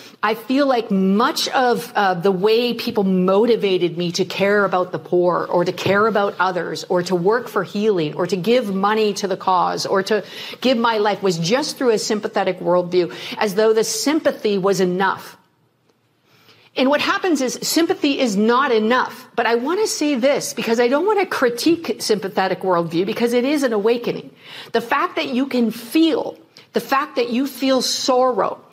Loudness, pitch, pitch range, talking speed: -19 LUFS, 220 Hz, 195-255 Hz, 185 wpm